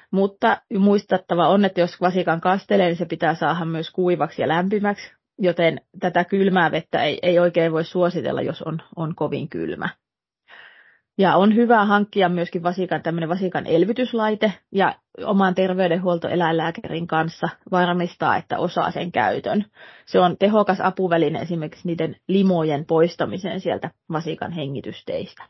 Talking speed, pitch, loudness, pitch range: 130 wpm, 175 Hz, -21 LUFS, 165-190 Hz